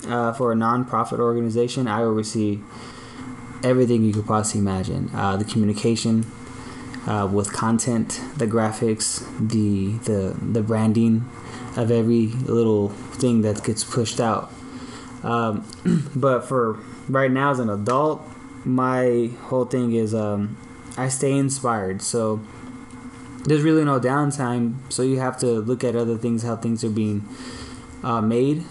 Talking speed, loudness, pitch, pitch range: 140 wpm, -22 LUFS, 120 Hz, 110-125 Hz